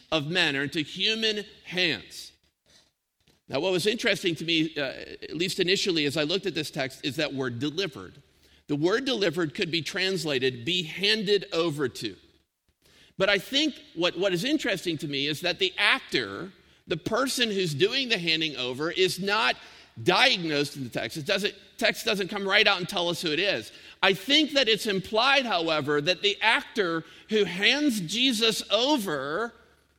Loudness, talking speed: -25 LUFS, 175 wpm